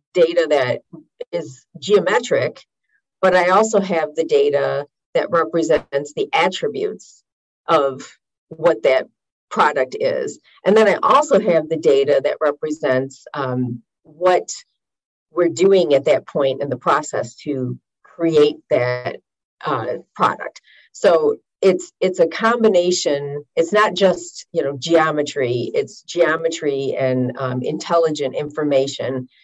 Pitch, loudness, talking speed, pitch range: 170 Hz, -18 LUFS, 120 wpm, 145-215 Hz